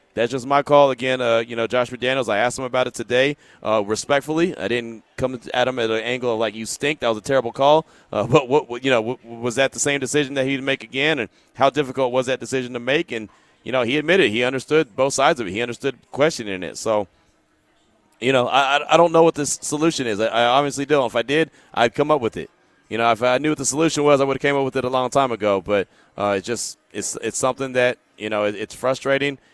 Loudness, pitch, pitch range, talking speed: -20 LUFS, 130 Hz, 115-140 Hz, 265 wpm